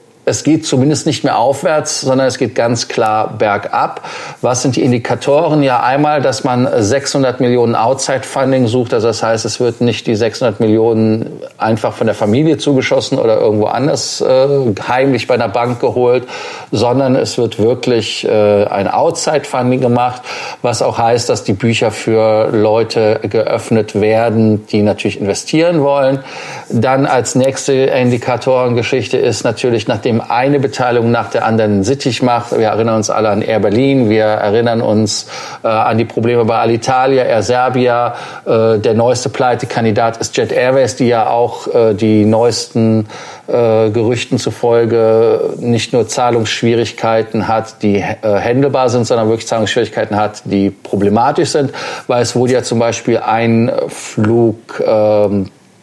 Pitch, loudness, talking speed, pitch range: 120 Hz, -13 LUFS, 150 wpm, 110-130 Hz